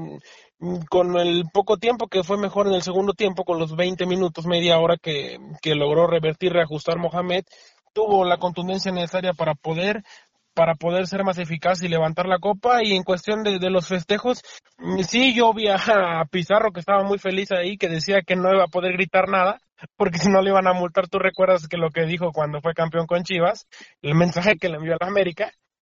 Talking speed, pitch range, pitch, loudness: 210 wpm, 170-195 Hz, 185 Hz, -21 LUFS